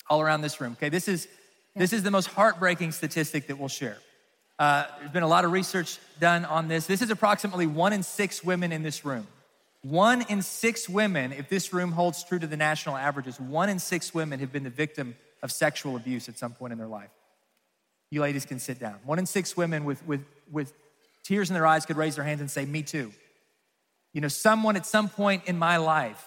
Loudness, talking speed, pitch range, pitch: -27 LUFS, 225 wpm, 145-185 Hz, 160 Hz